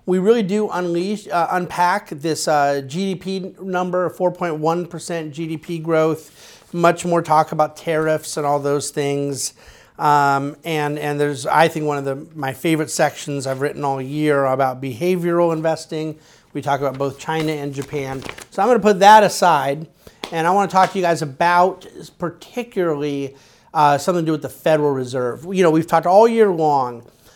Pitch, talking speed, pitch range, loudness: 160 Hz, 180 wpm, 145-175 Hz, -19 LUFS